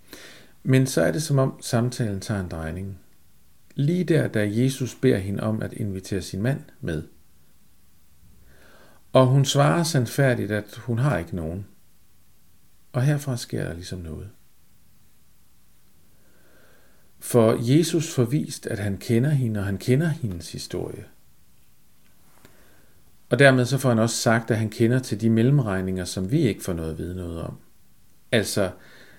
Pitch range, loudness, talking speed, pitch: 90-130 Hz, -23 LUFS, 150 wpm, 110 Hz